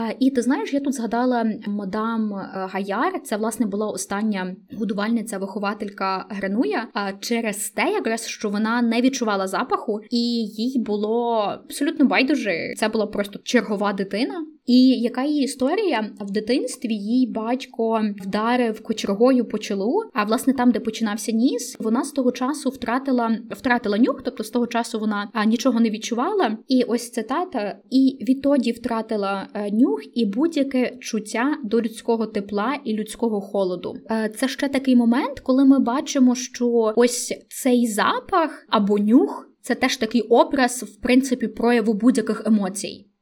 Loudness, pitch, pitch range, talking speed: -22 LUFS, 230 Hz, 215-255 Hz, 150 wpm